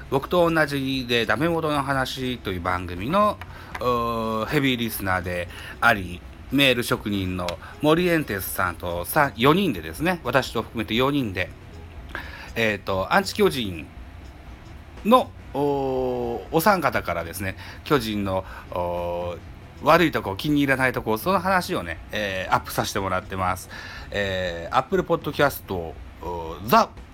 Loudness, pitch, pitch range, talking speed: -23 LUFS, 110 Hz, 90-135 Hz, 235 characters per minute